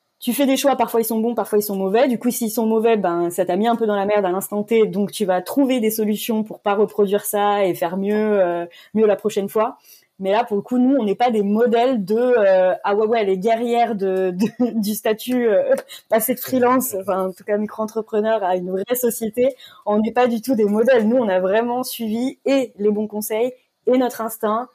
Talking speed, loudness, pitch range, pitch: 245 wpm, -19 LUFS, 205-240 Hz, 220 Hz